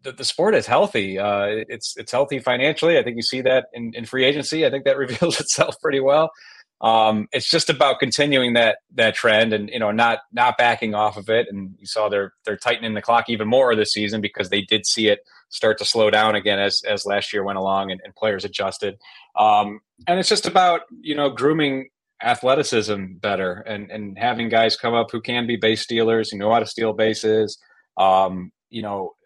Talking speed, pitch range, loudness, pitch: 215 wpm, 105-135 Hz, -20 LUFS, 115 Hz